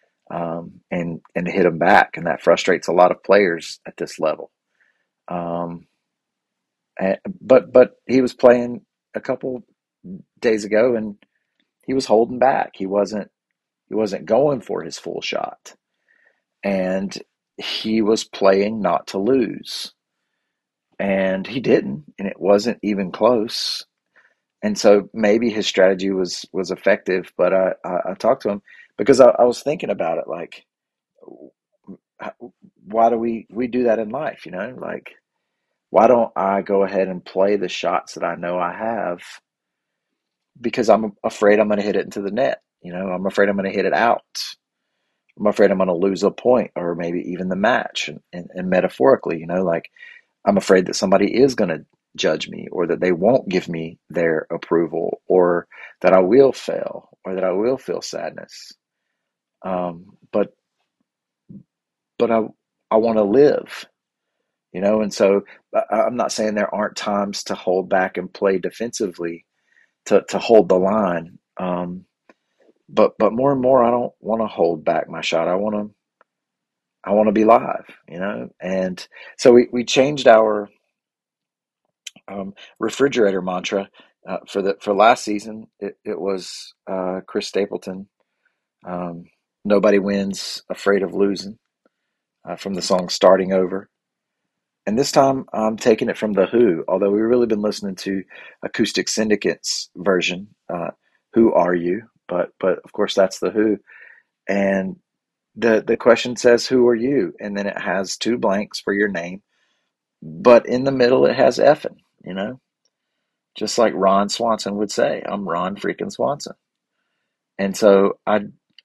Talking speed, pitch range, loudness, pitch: 165 wpm, 95-110 Hz, -19 LUFS, 100 Hz